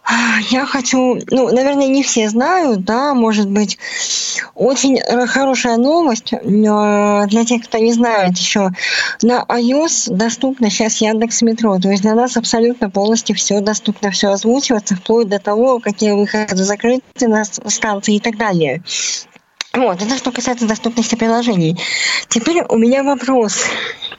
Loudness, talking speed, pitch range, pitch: -14 LUFS, 140 wpm, 210-250 Hz, 230 Hz